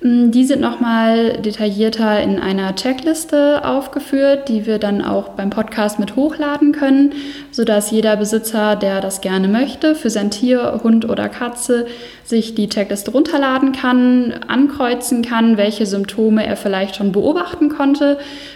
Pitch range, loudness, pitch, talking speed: 210-275 Hz, -16 LUFS, 235 Hz, 140 wpm